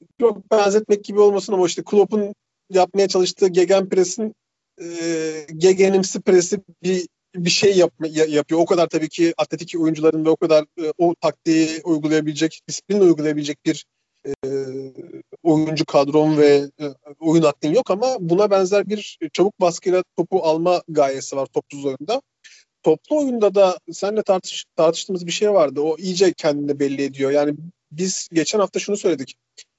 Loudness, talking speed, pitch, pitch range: -19 LUFS, 150 wpm, 170 Hz, 155-195 Hz